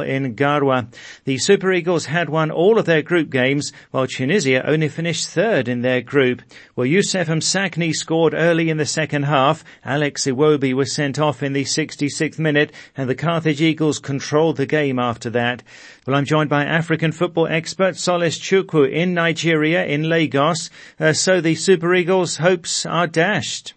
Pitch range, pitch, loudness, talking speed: 140-170 Hz, 155 Hz, -18 LUFS, 170 wpm